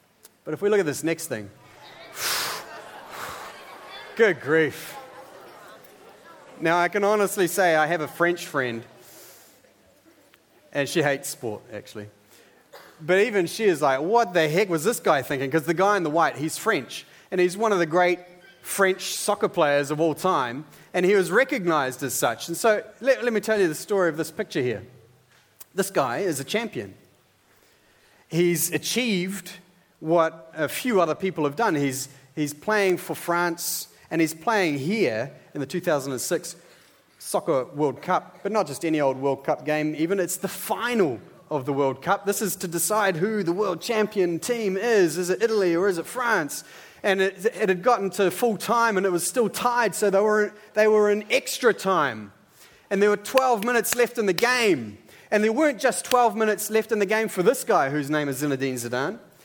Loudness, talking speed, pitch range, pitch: -24 LUFS, 190 wpm, 155-210 Hz, 180 Hz